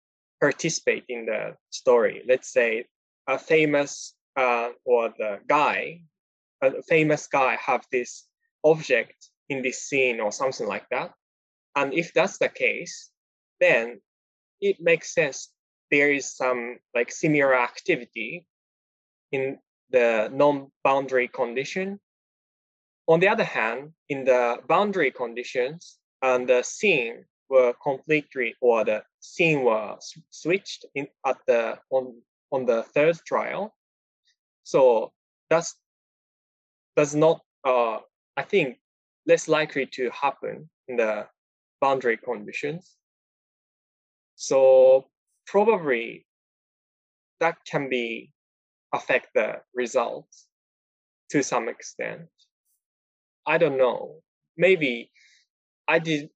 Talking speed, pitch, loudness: 110 wpm, 160 Hz, -24 LUFS